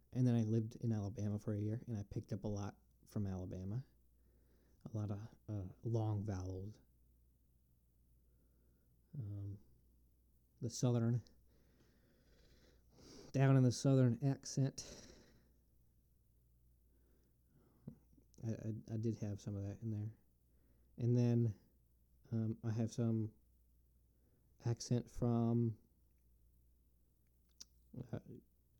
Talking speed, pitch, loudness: 105 wpm, 100 Hz, -40 LUFS